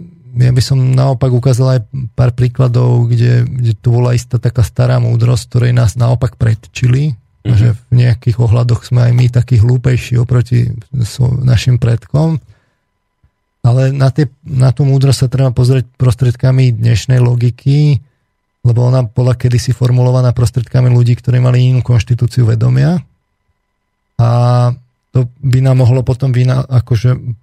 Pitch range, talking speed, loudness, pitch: 120-130 Hz, 140 wpm, -12 LUFS, 125 Hz